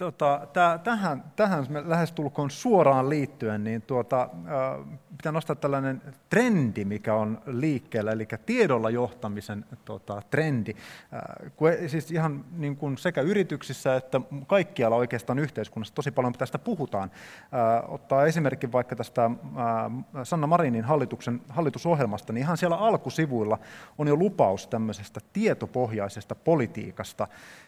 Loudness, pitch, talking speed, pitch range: -27 LUFS, 135 Hz, 115 wpm, 115-155 Hz